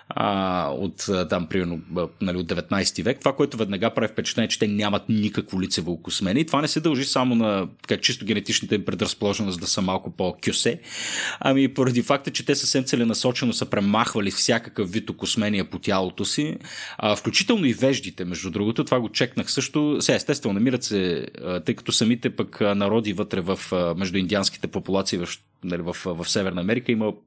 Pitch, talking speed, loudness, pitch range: 105 Hz, 170 wpm, -23 LUFS, 95-125 Hz